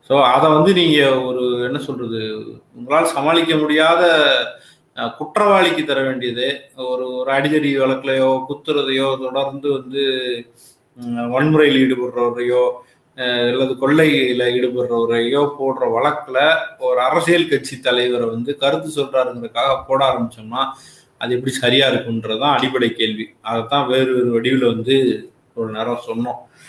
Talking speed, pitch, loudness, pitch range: 110 wpm, 130 Hz, -17 LUFS, 125-140 Hz